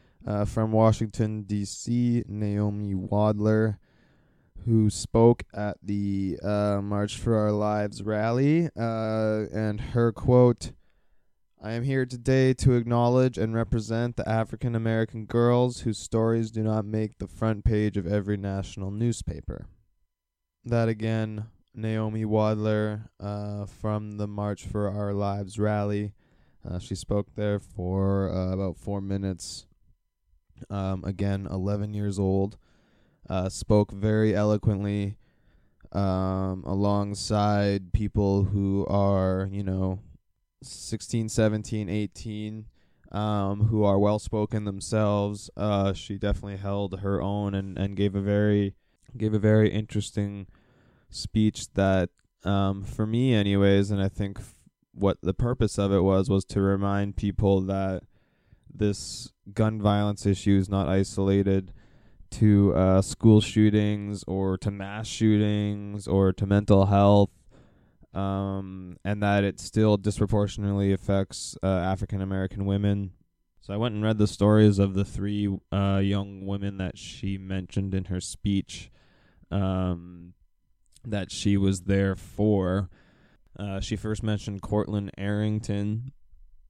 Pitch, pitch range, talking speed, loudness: 100 Hz, 95-110 Hz, 130 wpm, -26 LUFS